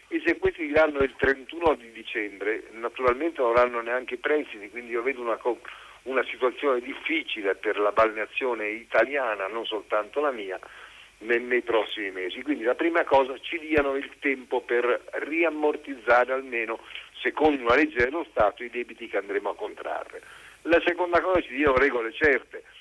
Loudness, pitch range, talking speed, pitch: -26 LUFS, 120-175 Hz, 160 wpm, 145 Hz